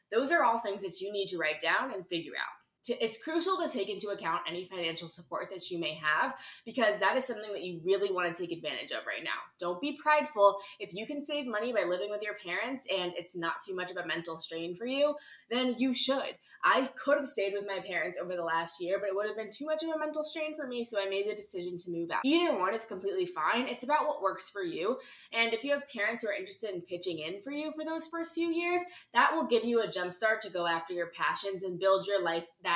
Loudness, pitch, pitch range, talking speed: -32 LUFS, 200 Hz, 180-275 Hz, 265 wpm